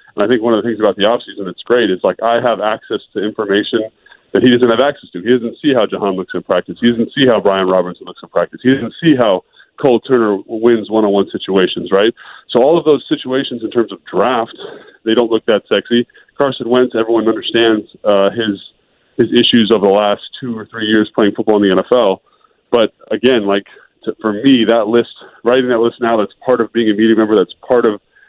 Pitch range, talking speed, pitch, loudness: 105-120 Hz, 225 wpm, 115 Hz, -14 LUFS